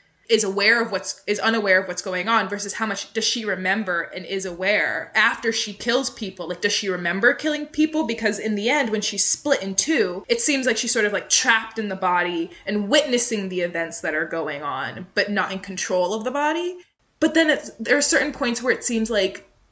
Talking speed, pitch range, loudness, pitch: 230 wpm, 190-240 Hz, -22 LUFS, 210 Hz